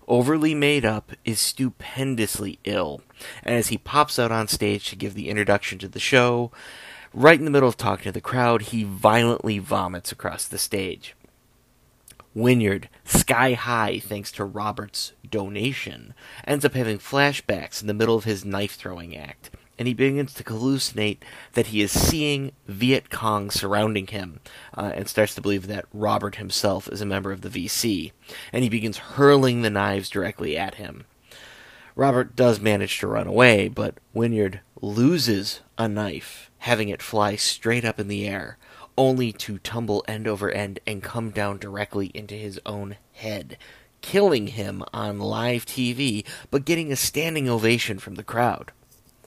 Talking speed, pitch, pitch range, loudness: 165 wpm, 110 Hz, 100-125 Hz, -23 LUFS